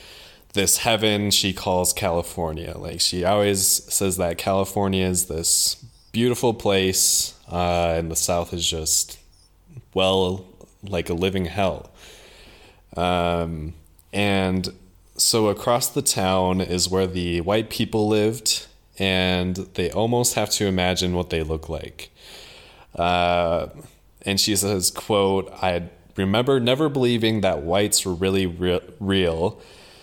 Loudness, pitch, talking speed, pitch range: -21 LUFS, 95 Hz, 125 wpm, 85-100 Hz